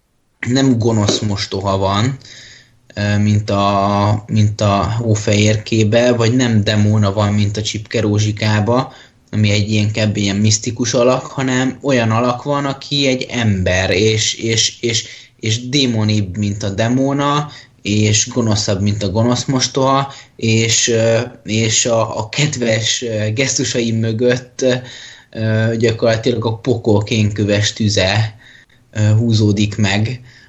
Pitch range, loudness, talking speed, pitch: 105-125 Hz, -15 LUFS, 115 wpm, 115 Hz